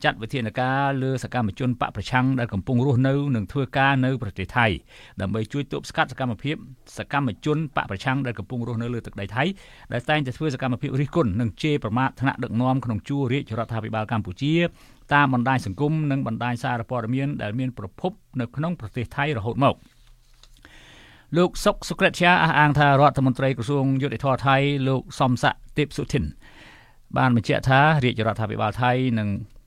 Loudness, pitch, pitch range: -23 LUFS, 130 Hz, 120-145 Hz